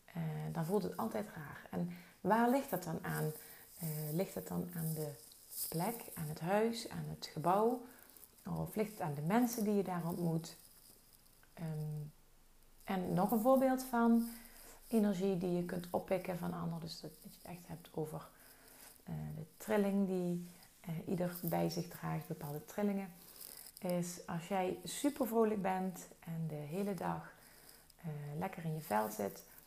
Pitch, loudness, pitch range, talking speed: 175 Hz, -38 LUFS, 155-200 Hz, 165 wpm